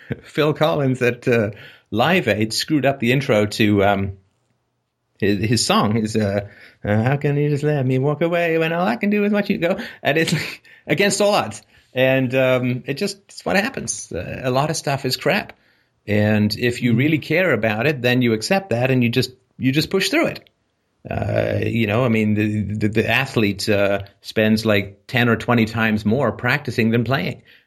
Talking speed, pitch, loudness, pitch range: 200 wpm, 125 Hz, -19 LUFS, 110-145 Hz